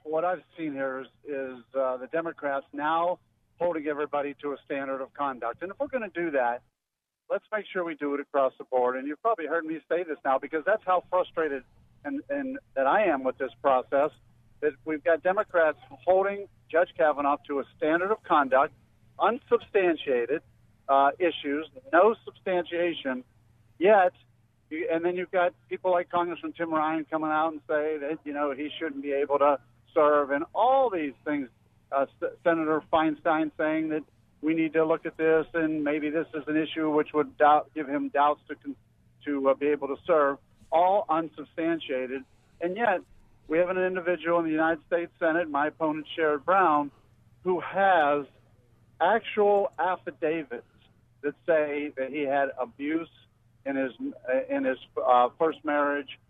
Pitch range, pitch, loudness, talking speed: 135-170 Hz, 150 Hz, -27 LUFS, 175 wpm